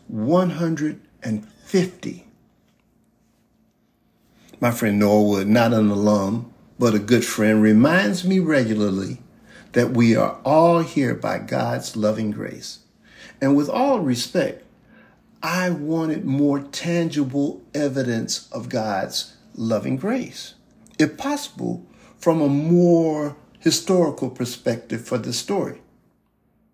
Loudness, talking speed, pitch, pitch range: -21 LUFS, 105 wpm, 140 Hz, 110-165 Hz